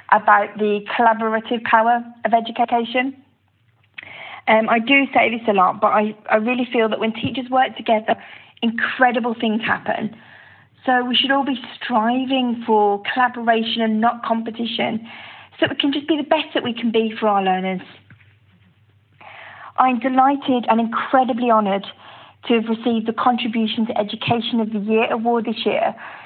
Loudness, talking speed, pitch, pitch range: -19 LUFS, 160 wpm, 230 Hz, 215-250 Hz